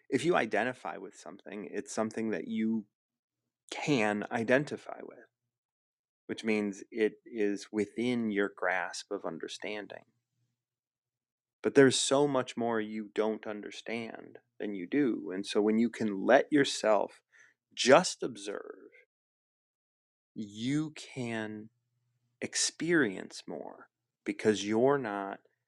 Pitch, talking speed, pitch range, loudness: 110 Hz, 110 wpm, 105-120 Hz, -31 LUFS